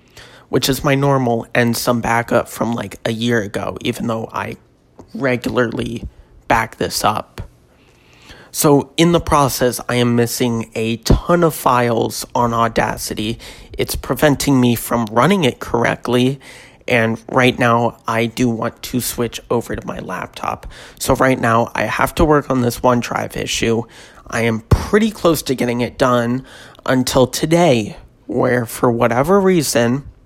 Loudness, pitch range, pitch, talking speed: -17 LUFS, 115-135 Hz, 120 Hz, 150 wpm